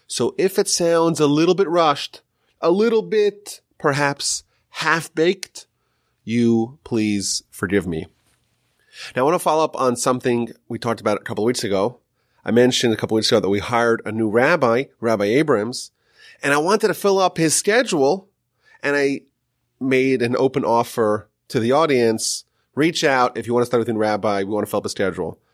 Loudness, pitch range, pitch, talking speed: -19 LUFS, 115-150 Hz, 120 Hz, 195 wpm